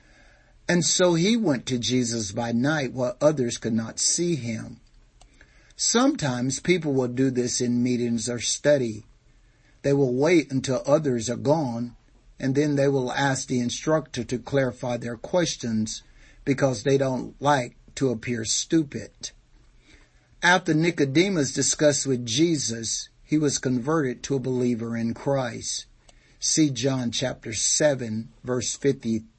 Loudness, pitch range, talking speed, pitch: -24 LUFS, 120-145 Hz, 135 wpm, 130 Hz